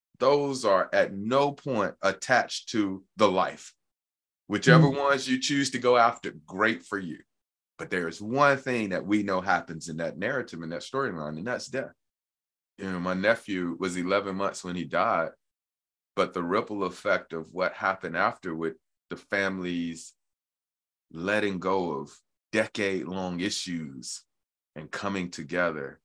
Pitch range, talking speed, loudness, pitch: 85-105 Hz, 150 wpm, -28 LUFS, 95 Hz